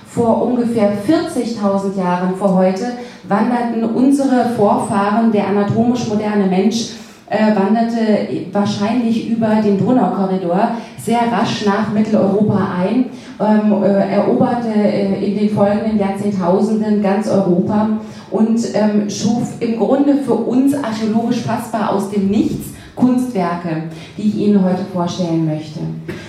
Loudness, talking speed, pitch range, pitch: -16 LUFS, 110 wpm, 195-230 Hz, 210 Hz